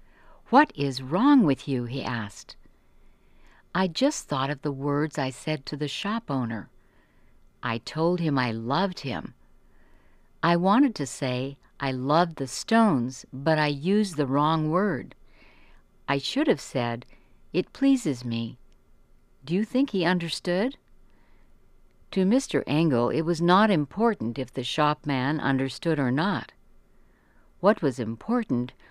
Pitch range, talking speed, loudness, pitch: 130-180 Hz, 140 wpm, -26 LUFS, 145 Hz